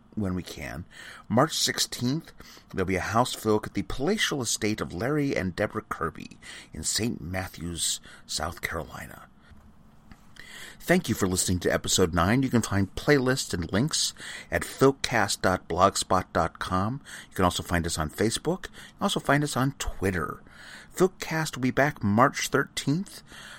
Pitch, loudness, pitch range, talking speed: 105 Hz, -27 LUFS, 90-135 Hz, 150 wpm